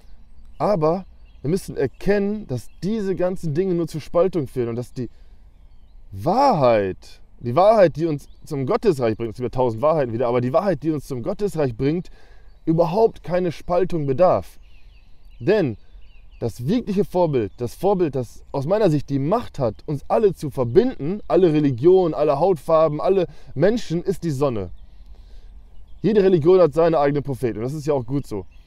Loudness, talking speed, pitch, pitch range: -21 LUFS, 165 wpm, 145 Hz, 115-175 Hz